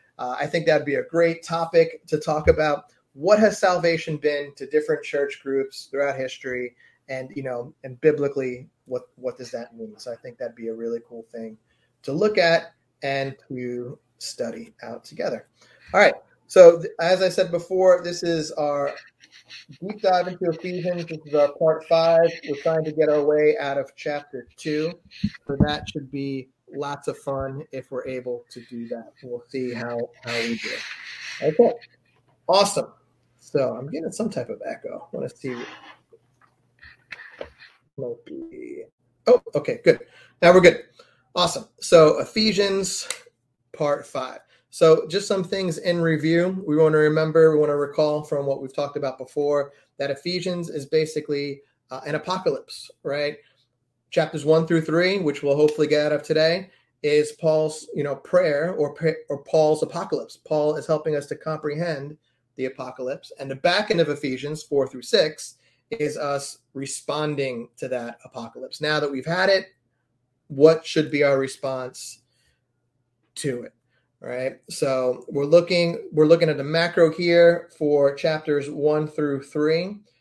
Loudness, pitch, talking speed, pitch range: -22 LUFS, 150 Hz, 165 wpm, 135-165 Hz